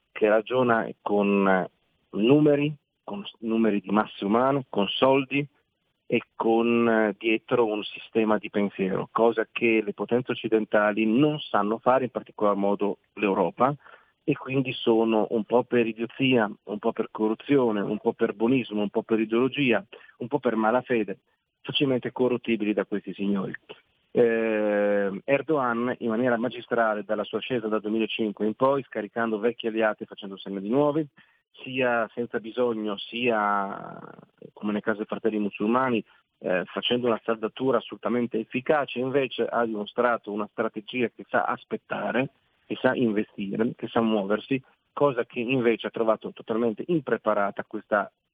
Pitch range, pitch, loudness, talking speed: 105-125 Hz, 115 Hz, -26 LUFS, 145 wpm